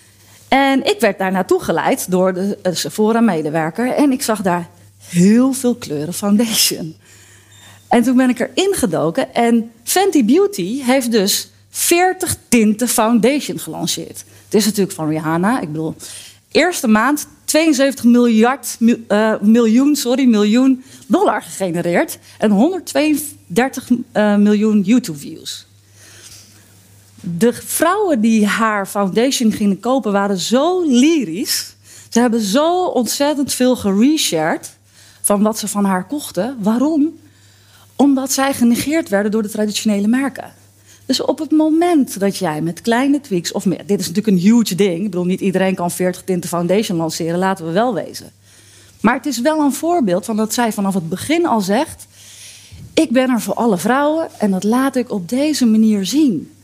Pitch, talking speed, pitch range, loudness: 215 Hz, 155 wpm, 180-260 Hz, -16 LUFS